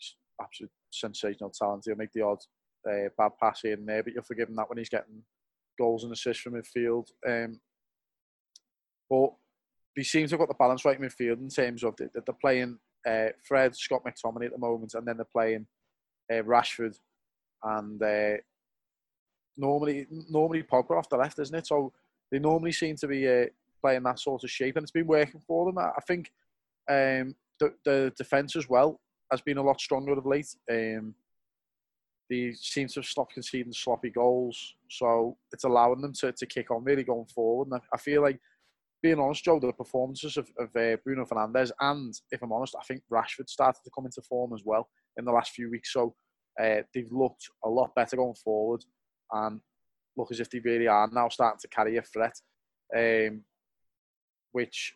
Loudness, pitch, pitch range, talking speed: -29 LUFS, 125 Hz, 115-135 Hz, 195 wpm